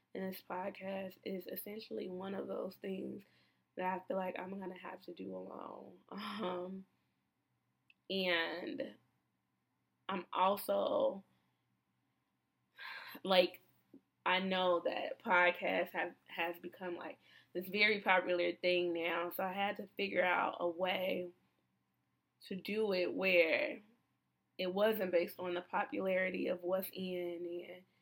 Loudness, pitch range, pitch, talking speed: -37 LUFS, 175-190 Hz, 185 Hz, 125 wpm